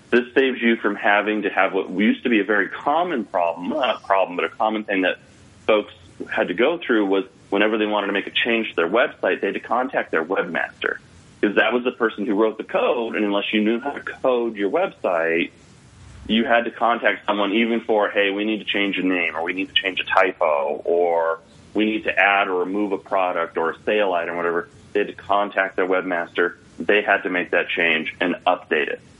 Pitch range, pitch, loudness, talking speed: 95-110 Hz, 105 Hz, -21 LUFS, 235 wpm